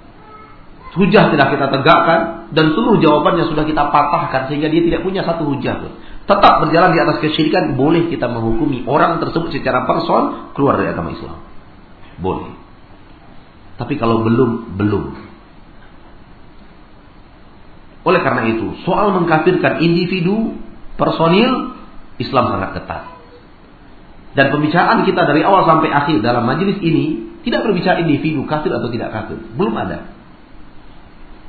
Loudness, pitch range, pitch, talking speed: -15 LUFS, 130-180 Hz, 155 Hz, 125 wpm